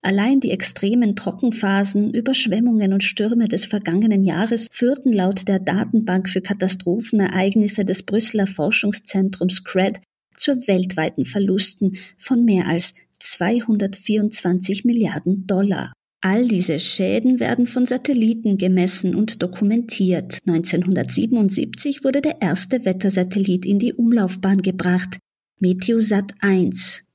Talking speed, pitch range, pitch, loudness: 110 wpm, 185-225 Hz, 200 Hz, -19 LUFS